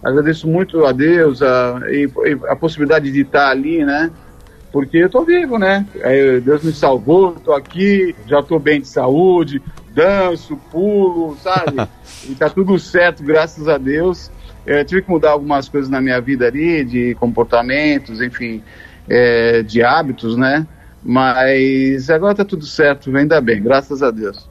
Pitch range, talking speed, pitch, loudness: 130-170 Hz, 160 wpm, 145 Hz, -14 LUFS